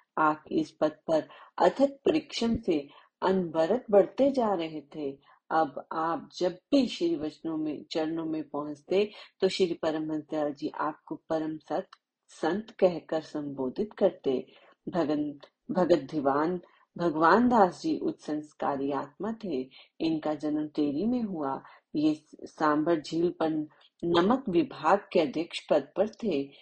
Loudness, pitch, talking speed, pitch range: -29 LUFS, 165 Hz, 130 wpm, 155-205 Hz